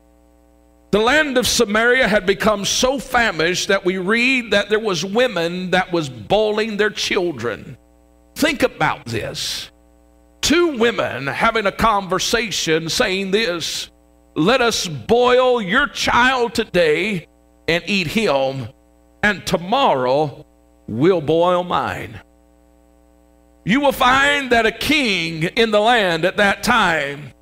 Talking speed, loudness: 125 wpm, -17 LUFS